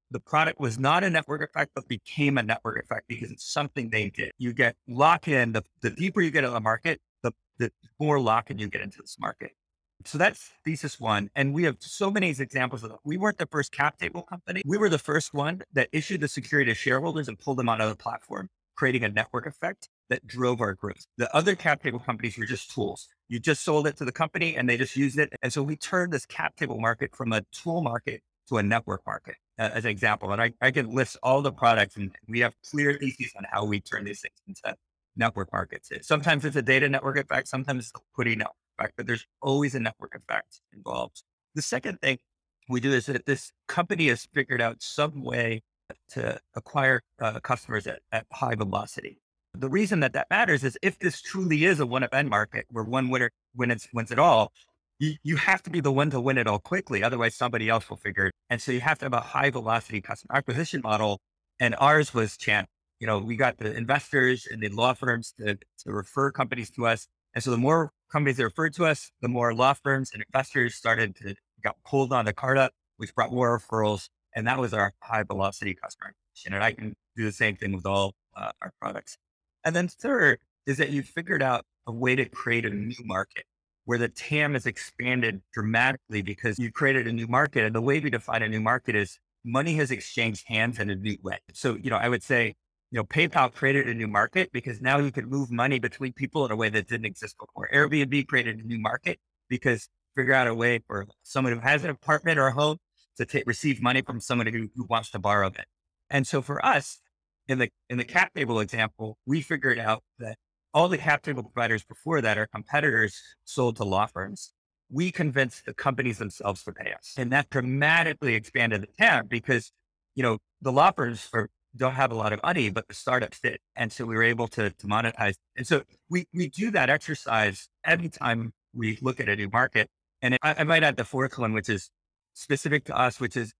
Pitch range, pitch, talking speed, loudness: 110-145 Hz, 125 Hz, 225 wpm, -26 LUFS